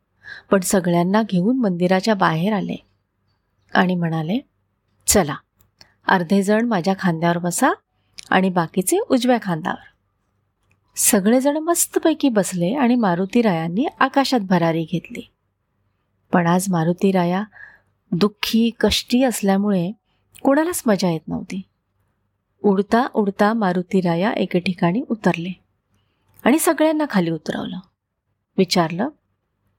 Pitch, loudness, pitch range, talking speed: 190 Hz, -19 LUFS, 165-225 Hz, 100 wpm